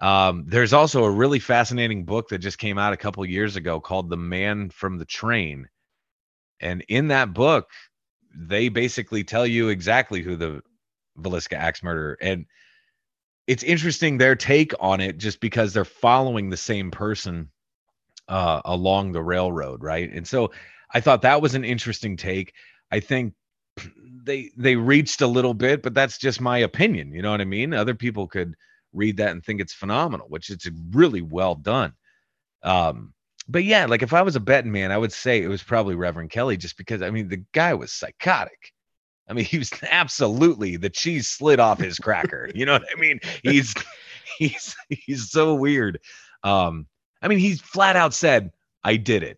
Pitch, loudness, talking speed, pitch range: 105 Hz, -22 LUFS, 185 wpm, 95-130 Hz